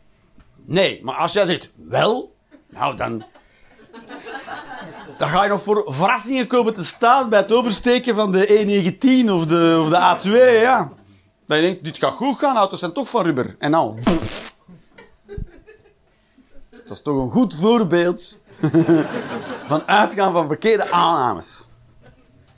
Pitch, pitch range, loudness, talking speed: 190 Hz, 160-230 Hz, -18 LUFS, 145 wpm